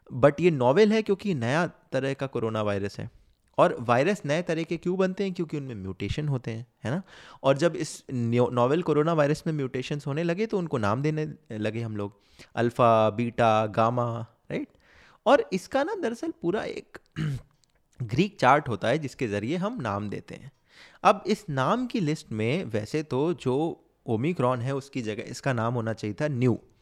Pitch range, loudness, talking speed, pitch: 115-170 Hz, -27 LUFS, 185 wpm, 135 Hz